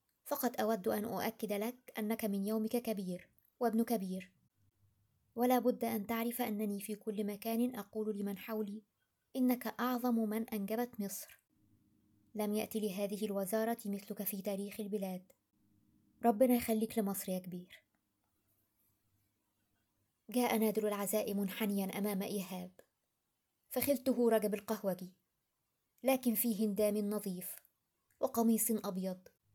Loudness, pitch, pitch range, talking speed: -37 LUFS, 210 Hz, 185-225 Hz, 110 wpm